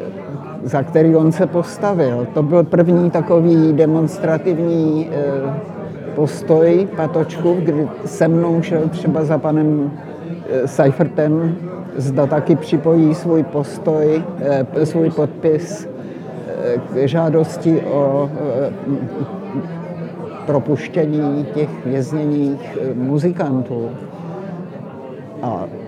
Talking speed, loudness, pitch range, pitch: 80 wpm, -17 LUFS, 145-170 Hz, 160 Hz